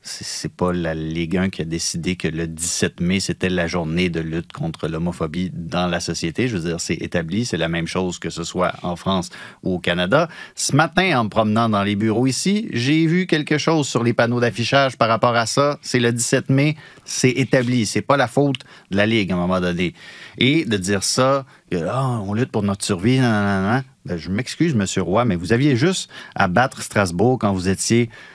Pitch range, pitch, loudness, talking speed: 90-130 Hz, 110 Hz, -20 LUFS, 220 wpm